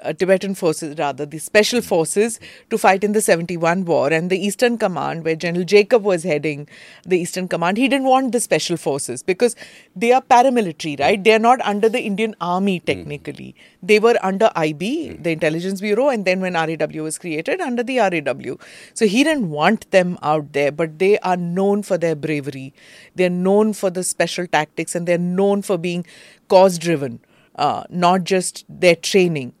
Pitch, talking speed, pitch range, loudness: 185 Hz, 185 wpm, 165-210 Hz, -18 LUFS